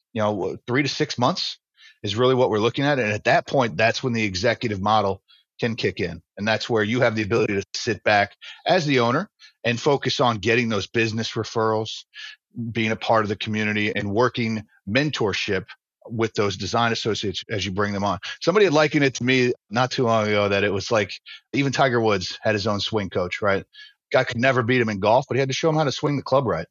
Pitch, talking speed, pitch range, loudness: 115 Hz, 235 wpm, 105-130 Hz, -22 LUFS